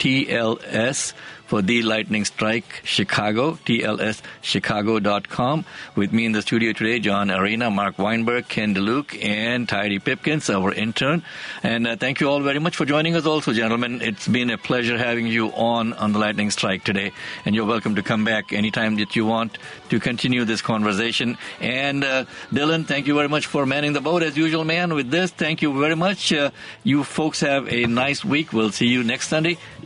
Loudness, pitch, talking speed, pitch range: -21 LUFS, 120 Hz, 190 wpm, 110-145 Hz